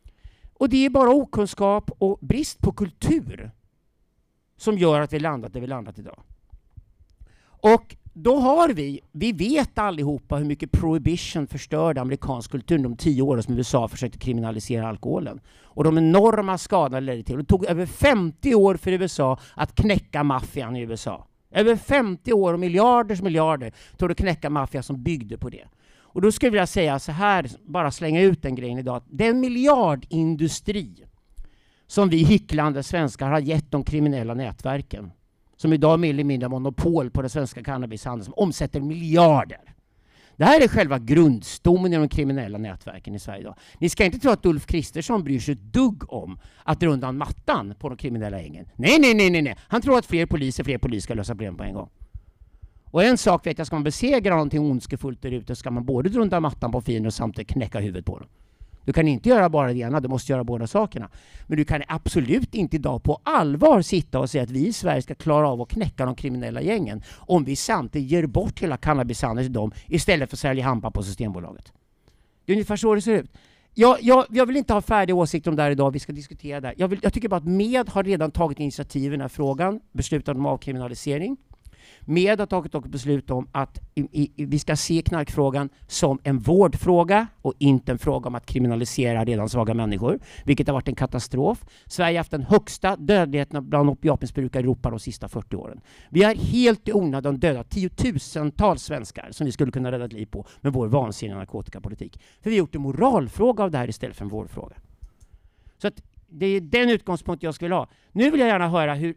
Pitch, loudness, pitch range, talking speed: 145 Hz, -22 LUFS, 125-180 Hz, 205 wpm